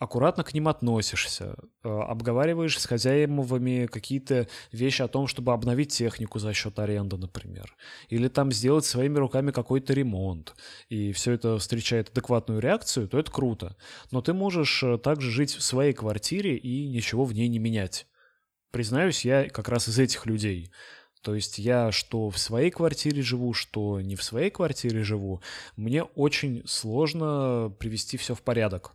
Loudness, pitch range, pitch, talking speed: -27 LUFS, 110-135 Hz, 120 Hz, 160 wpm